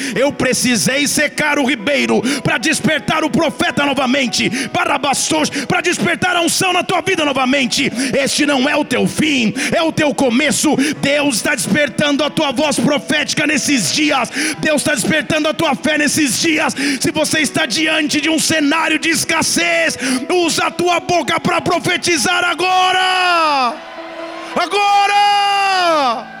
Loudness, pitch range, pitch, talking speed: -14 LUFS, 275-335 Hz, 300 Hz, 145 wpm